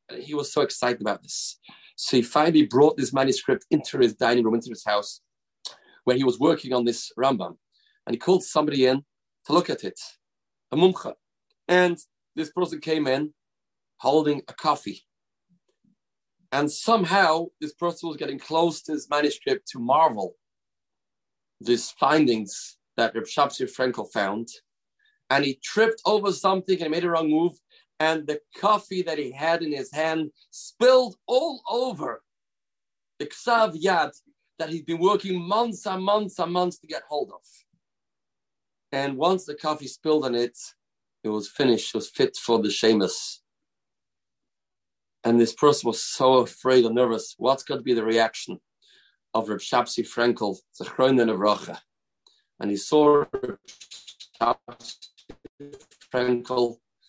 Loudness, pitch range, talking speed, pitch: -24 LUFS, 125-180 Hz, 150 wpm, 155 Hz